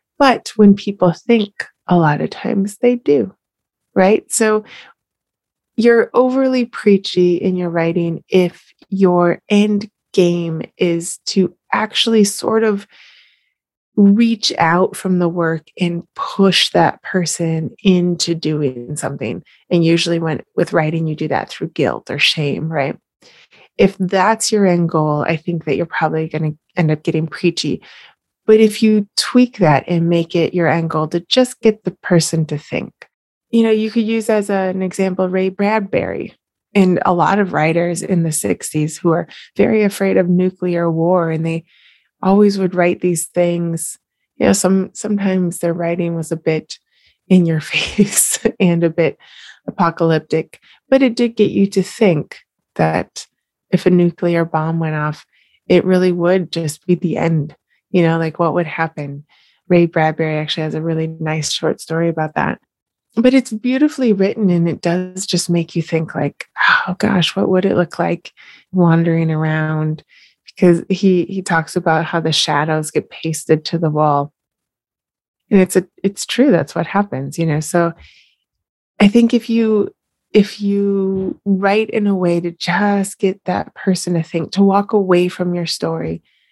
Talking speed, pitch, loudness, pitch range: 165 wpm, 175 Hz, -16 LUFS, 165-200 Hz